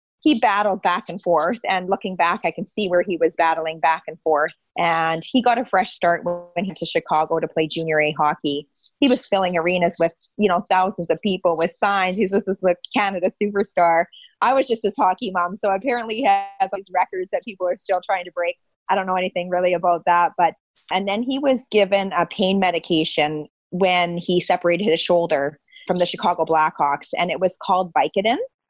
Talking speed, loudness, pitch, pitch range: 210 wpm, -20 LUFS, 180 Hz, 170-200 Hz